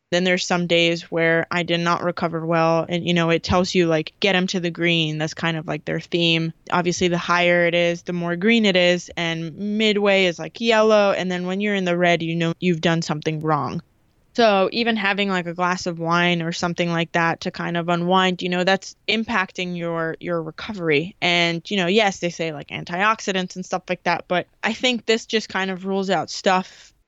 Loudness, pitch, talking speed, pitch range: -20 LUFS, 175 Hz, 225 wpm, 170-190 Hz